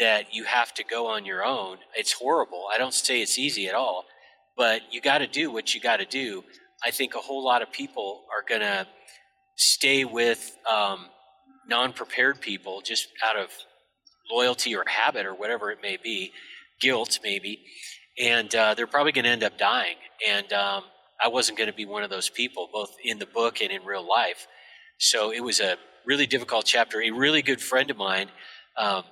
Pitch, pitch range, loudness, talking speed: 120 Hz, 110-135 Hz, -25 LUFS, 200 wpm